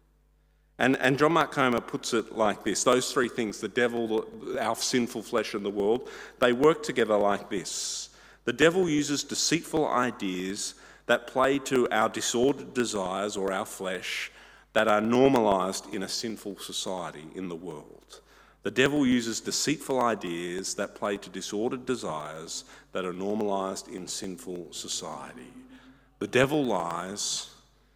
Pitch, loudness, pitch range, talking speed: 115 Hz, -28 LUFS, 95-130 Hz, 150 wpm